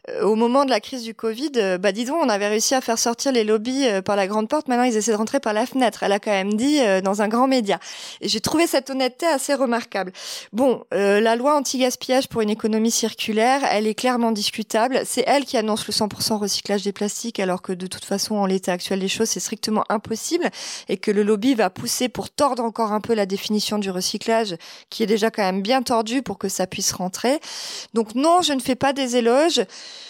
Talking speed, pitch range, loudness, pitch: 235 wpm, 205-260 Hz, -21 LUFS, 225 Hz